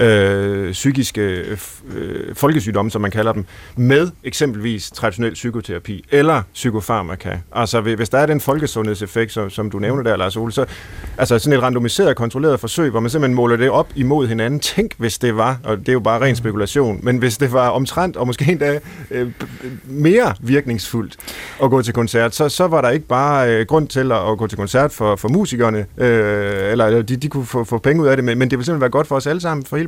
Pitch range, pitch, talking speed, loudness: 110-140 Hz, 120 Hz, 215 wpm, -17 LUFS